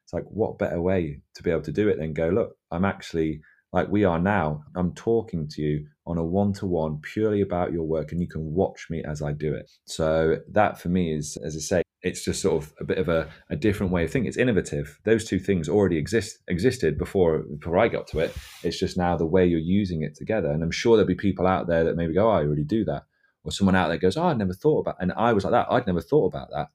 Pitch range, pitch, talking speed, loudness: 80-95 Hz, 85 Hz, 270 wpm, -25 LUFS